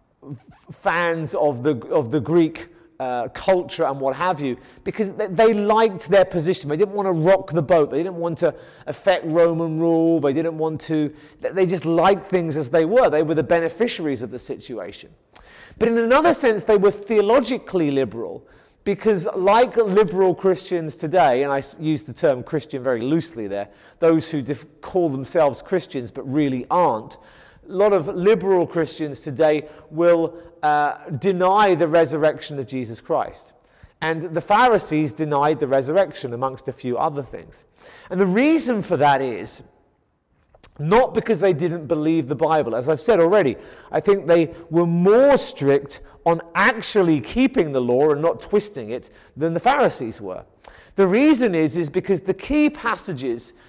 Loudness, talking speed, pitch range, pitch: -20 LUFS, 165 wpm, 150-195 Hz, 165 Hz